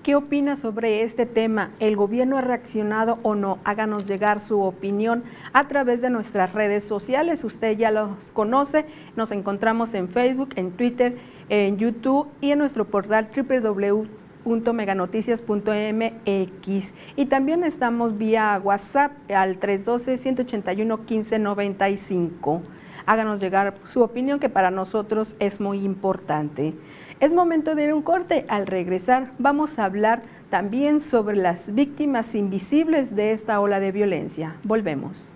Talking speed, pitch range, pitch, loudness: 135 wpm, 200-250 Hz, 220 Hz, -23 LUFS